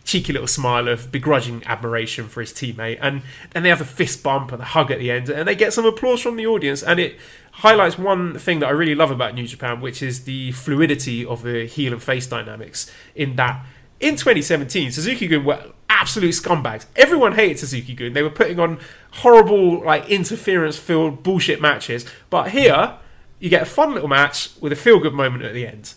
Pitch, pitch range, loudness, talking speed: 145 Hz, 125-170 Hz, -18 LUFS, 205 wpm